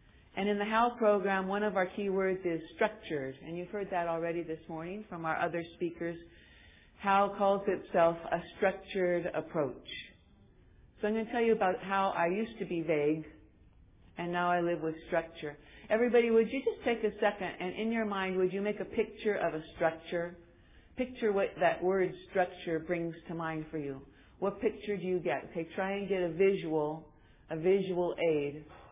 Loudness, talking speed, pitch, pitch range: -33 LUFS, 190 wpm, 175 Hz, 160-200 Hz